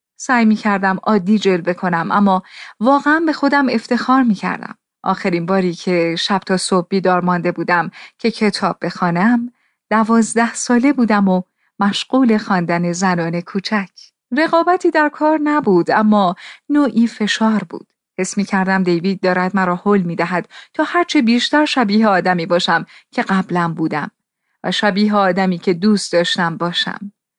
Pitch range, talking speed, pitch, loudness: 180-235 Hz, 145 wpm, 200 Hz, -16 LUFS